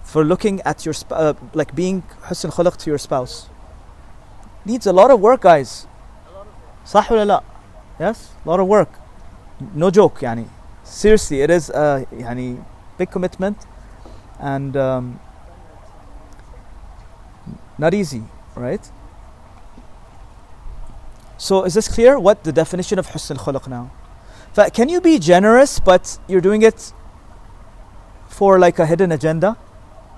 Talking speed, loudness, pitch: 135 wpm, -16 LUFS, 140 Hz